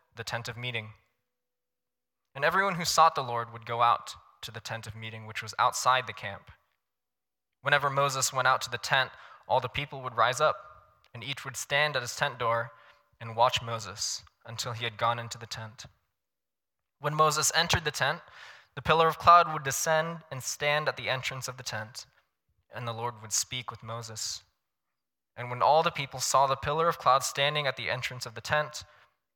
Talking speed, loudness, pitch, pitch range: 200 wpm, -28 LUFS, 120 Hz, 110-140 Hz